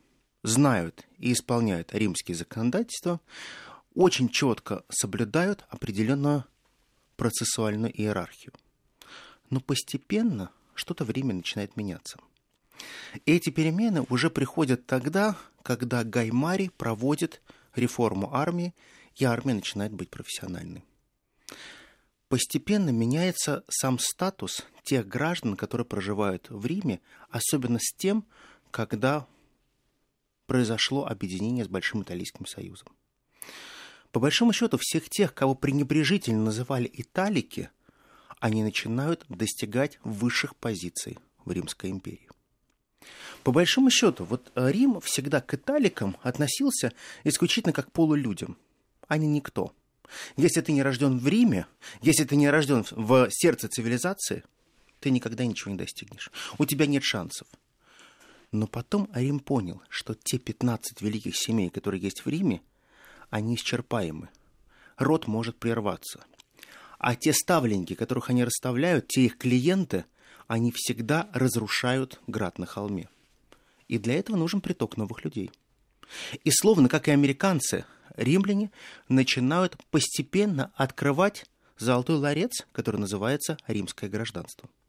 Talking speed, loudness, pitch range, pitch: 115 wpm, -27 LUFS, 115-155 Hz, 130 Hz